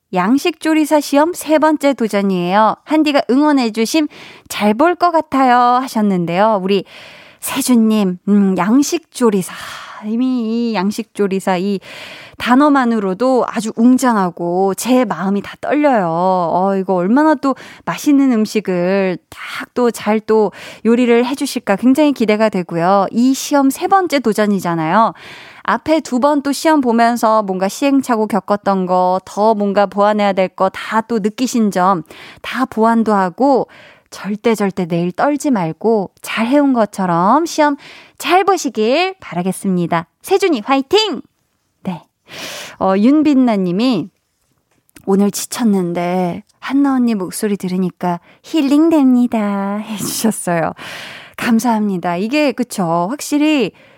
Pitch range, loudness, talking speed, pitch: 195-270 Hz, -15 LUFS, 270 characters per minute, 225 Hz